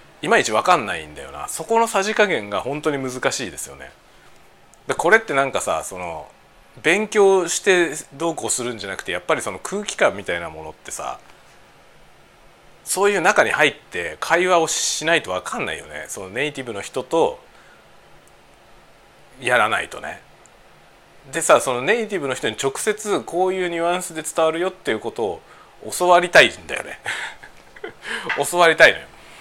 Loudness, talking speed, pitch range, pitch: -20 LUFS, 335 characters per minute, 140-200 Hz, 175 Hz